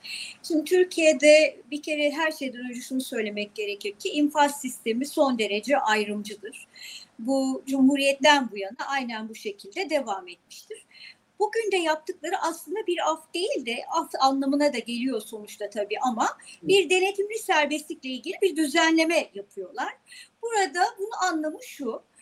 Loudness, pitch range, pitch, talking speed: -25 LUFS, 255-365 Hz, 295 Hz, 140 wpm